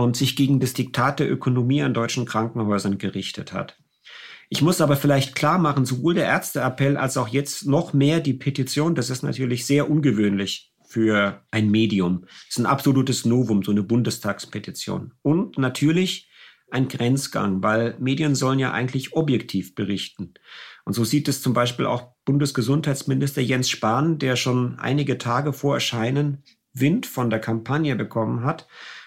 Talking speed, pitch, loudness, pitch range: 160 wpm, 130 Hz, -22 LUFS, 115-140 Hz